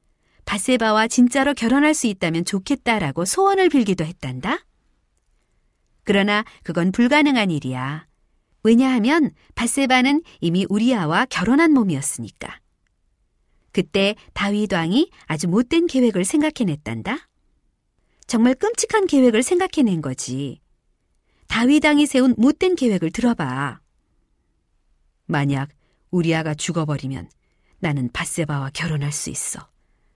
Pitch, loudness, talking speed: 200 Hz, -20 LUFS, 265 characters per minute